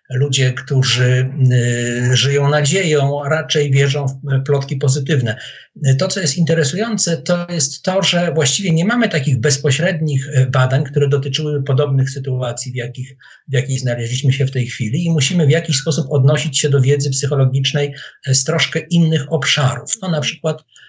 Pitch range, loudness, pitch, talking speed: 135-160 Hz, -16 LUFS, 145 Hz, 160 wpm